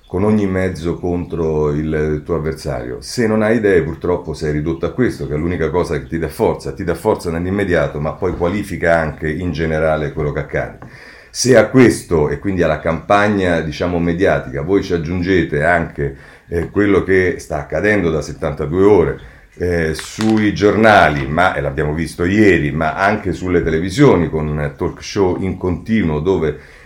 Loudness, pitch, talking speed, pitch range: -16 LUFS, 85 Hz, 170 wpm, 80-95 Hz